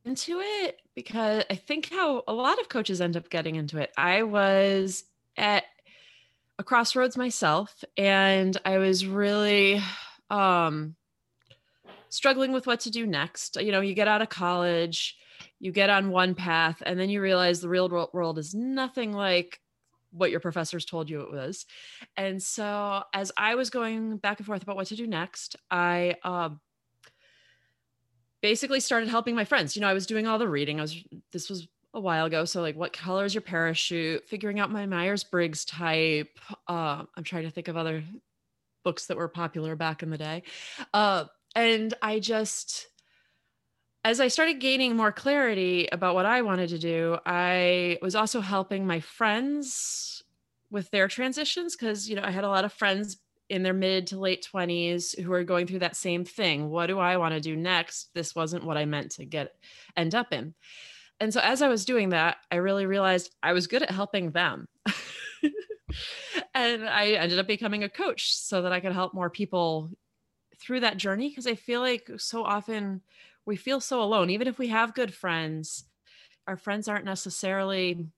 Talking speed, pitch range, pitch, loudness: 185 wpm, 175-220 Hz, 195 Hz, -27 LUFS